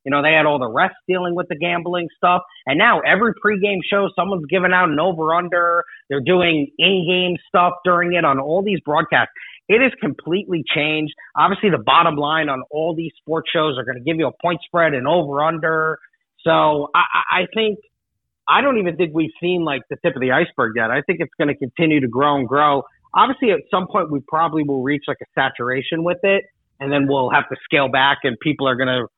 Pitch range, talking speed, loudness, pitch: 145-180 Hz, 225 wpm, -18 LUFS, 165 Hz